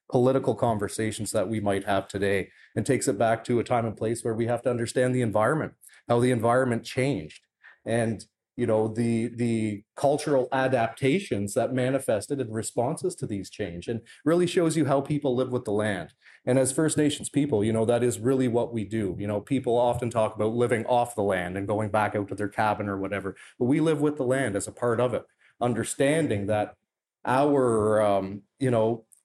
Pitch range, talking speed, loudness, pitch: 105-130 Hz, 205 wpm, -26 LUFS, 115 Hz